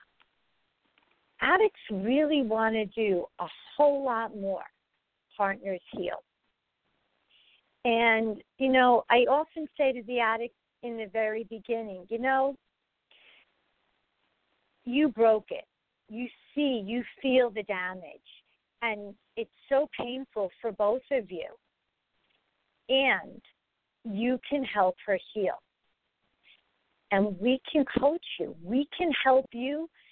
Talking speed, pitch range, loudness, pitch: 115 wpm, 210-270 Hz, -28 LUFS, 235 Hz